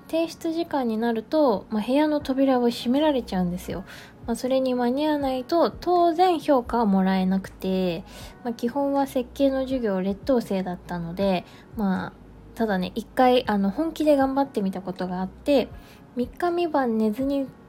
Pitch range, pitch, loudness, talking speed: 200-280 Hz, 250 Hz, -24 LUFS, 325 characters per minute